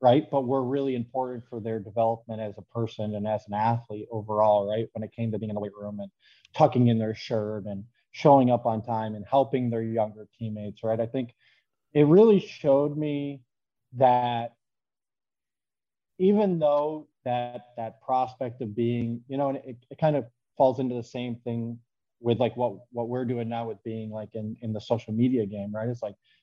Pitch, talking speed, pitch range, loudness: 120 Hz, 200 wpm, 110-130 Hz, -27 LUFS